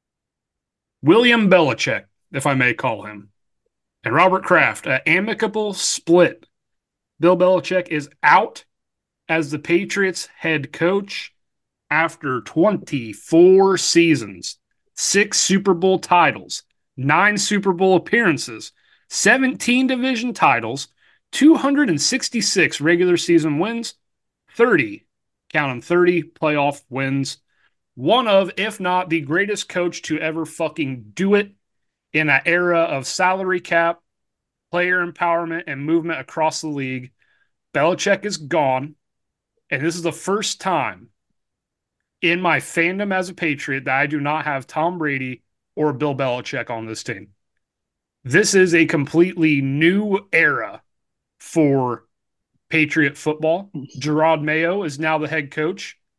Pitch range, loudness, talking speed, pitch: 145-185 Hz, -18 LUFS, 125 wpm, 165 Hz